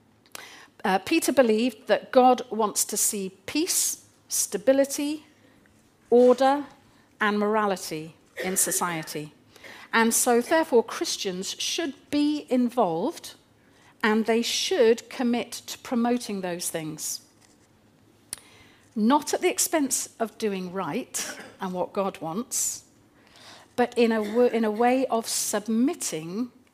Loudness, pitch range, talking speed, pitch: -25 LUFS, 200-265 Hz, 110 wpm, 230 Hz